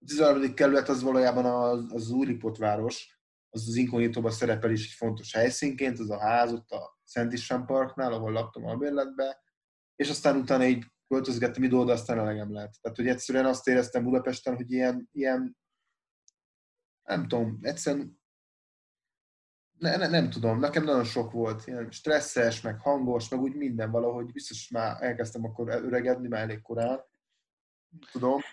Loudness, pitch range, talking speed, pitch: -29 LUFS, 115-135 Hz, 160 wpm, 125 Hz